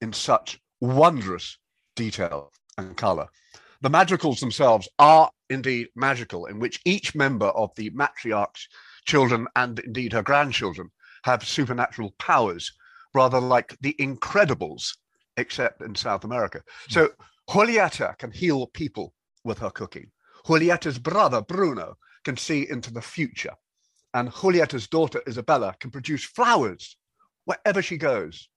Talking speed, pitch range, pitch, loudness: 130 wpm, 120-170 Hz, 135 Hz, -23 LUFS